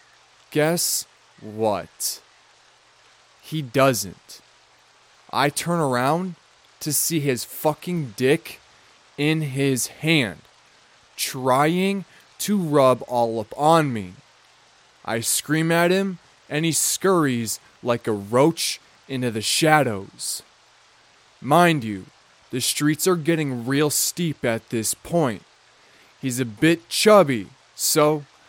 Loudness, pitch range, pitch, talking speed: -21 LUFS, 120-160 Hz, 145 Hz, 105 wpm